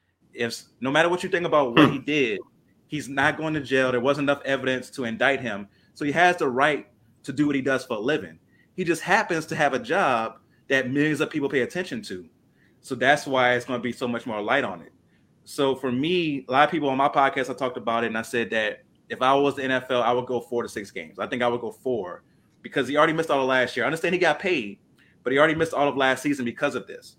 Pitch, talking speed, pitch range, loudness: 135 Hz, 270 wpm, 125-150 Hz, -24 LUFS